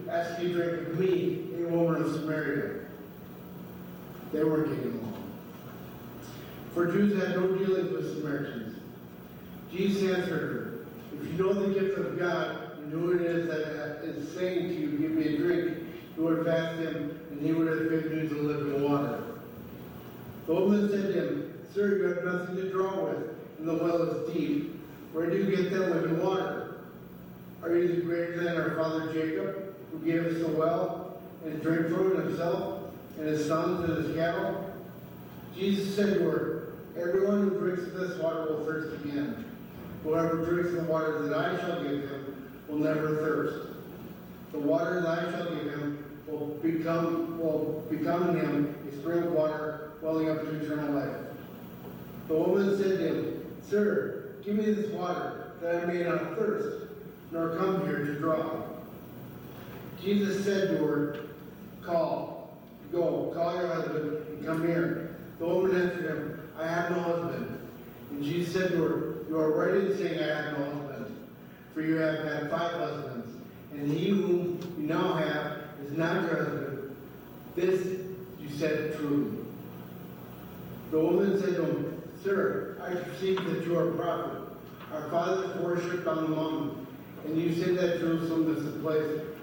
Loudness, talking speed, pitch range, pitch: -30 LUFS, 170 wpm, 150-175 Hz, 160 Hz